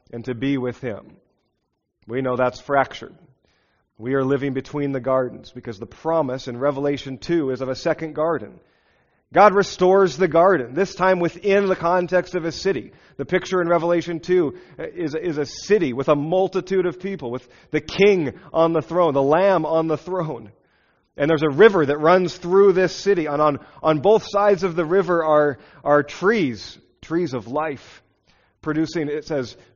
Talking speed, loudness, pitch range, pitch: 180 wpm, -20 LUFS, 135-180 Hz, 160 Hz